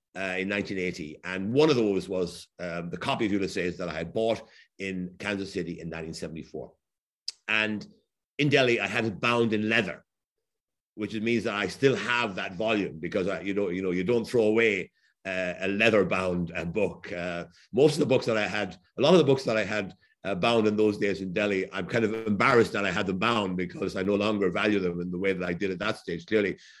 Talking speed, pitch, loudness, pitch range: 230 wpm, 100 Hz, -27 LUFS, 90-110 Hz